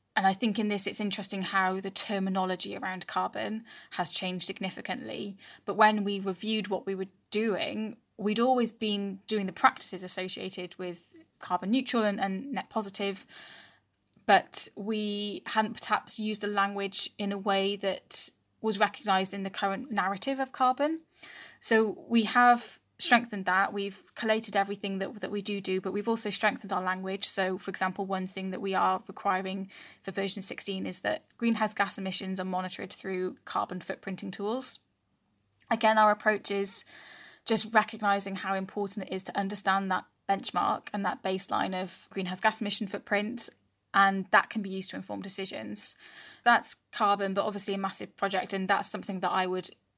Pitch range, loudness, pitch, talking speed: 190-215 Hz, -29 LUFS, 200 Hz, 170 wpm